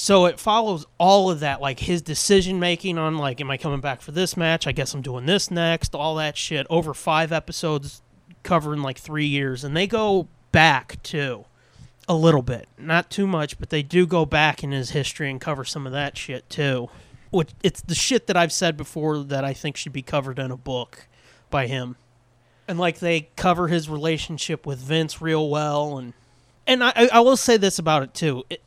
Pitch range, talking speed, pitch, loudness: 135-170 Hz, 210 wpm, 155 Hz, -22 LUFS